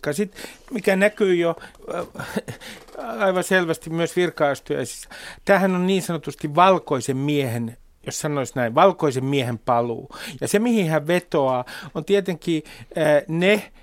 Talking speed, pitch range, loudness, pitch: 125 wpm, 140-190 Hz, -22 LUFS, 165 Hz